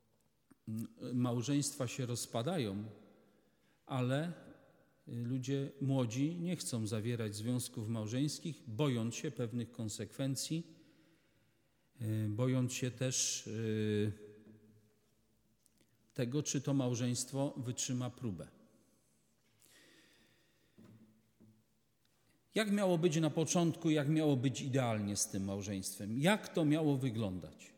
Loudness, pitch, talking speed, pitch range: -37 LUFS, 125 Hz, 85 wpm, 110-140 Hz